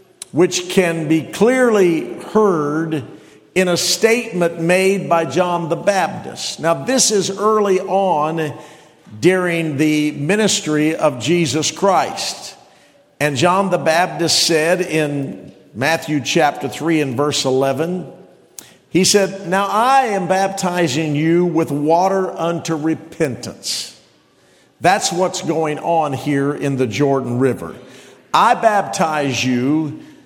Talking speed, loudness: 115 wpm, -17 LUFS